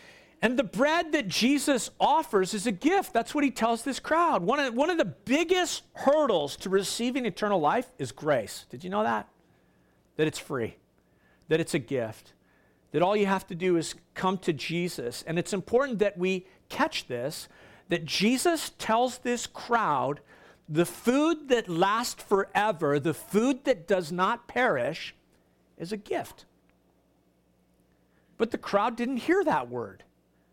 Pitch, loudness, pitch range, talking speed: 225 Hz, -28 LUFS, 180-275 Hz, 160 wpm